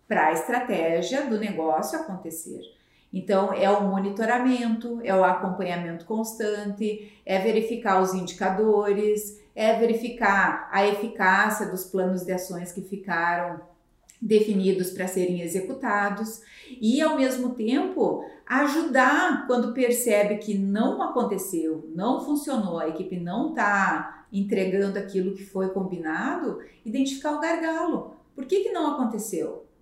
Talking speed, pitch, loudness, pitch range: 125 wpm, 210 Hz, -25 LUFS, 190-245 Hz